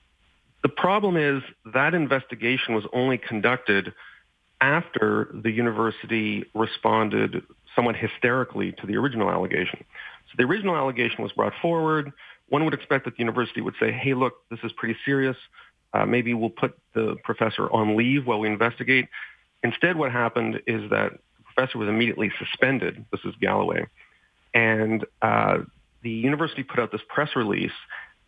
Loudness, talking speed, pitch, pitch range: -24 LUFS, 155 wpm, 120 Hz, 110-135 Hz